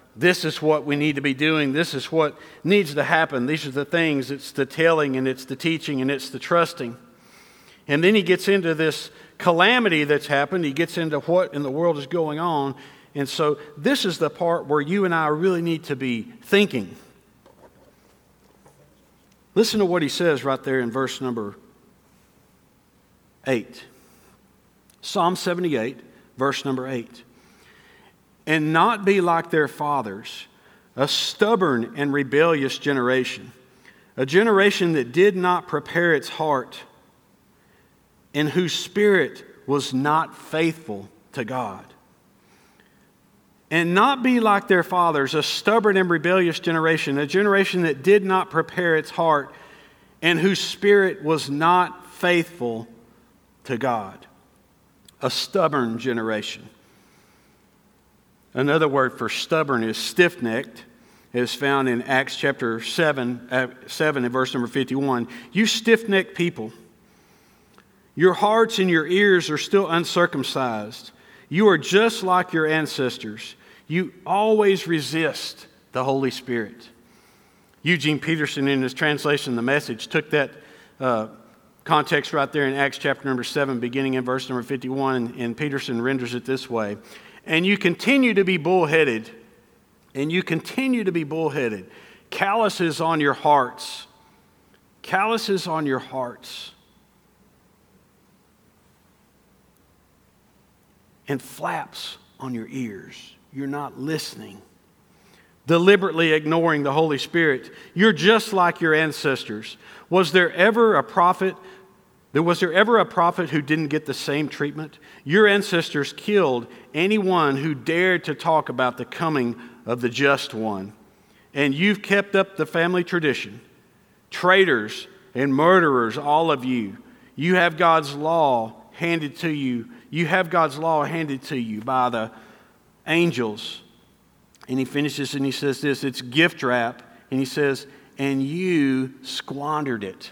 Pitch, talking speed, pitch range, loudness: 150 Hz, 140 wpm, 130-175 Hz, -21 LUFS